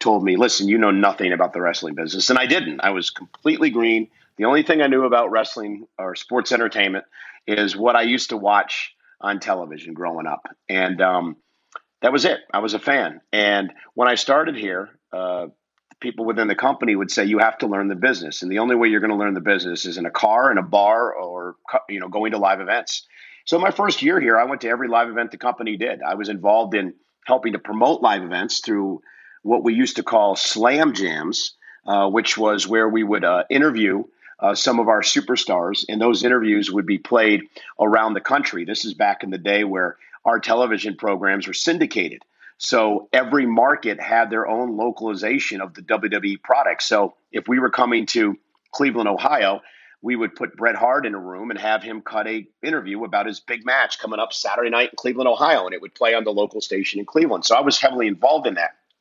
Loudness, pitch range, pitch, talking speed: -20 LUFS, 100-120 Hz, 110 Hz, 220 wpm